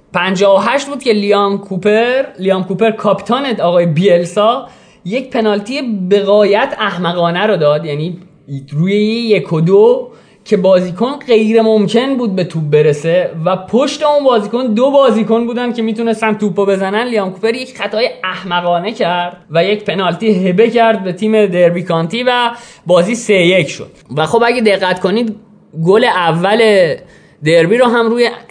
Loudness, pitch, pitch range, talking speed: -12 LUFS, 205 Hz, 180-230 Hz, 150 wpm